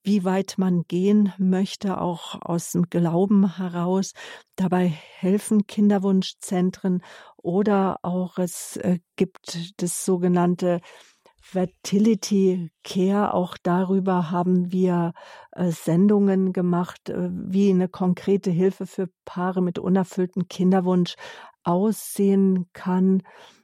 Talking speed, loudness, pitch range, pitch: 95 wpm, -23 LUFS, 180-195 Hz, 185 Hz